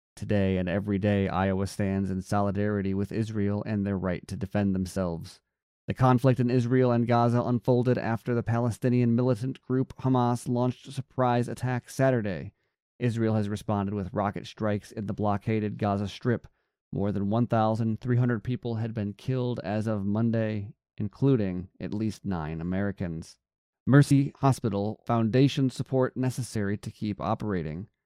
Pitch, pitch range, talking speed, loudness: 110 Hz, 100-125 Hz, 145 wpm, -28 LUFS